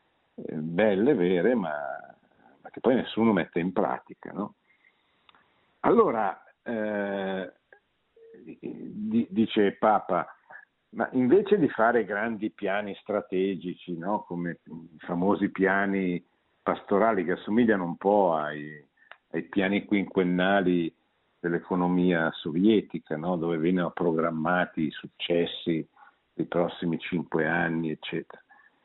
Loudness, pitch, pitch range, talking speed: -27 LUFS, 90 Hz, 85-105 Hz, 100 wpm